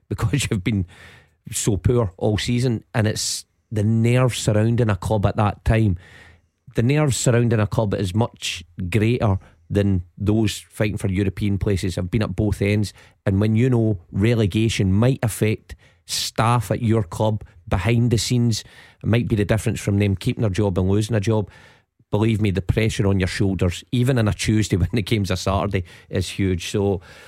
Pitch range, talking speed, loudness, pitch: 100-115 Hz, 185 wpm, -21 LUFS, 105 Hz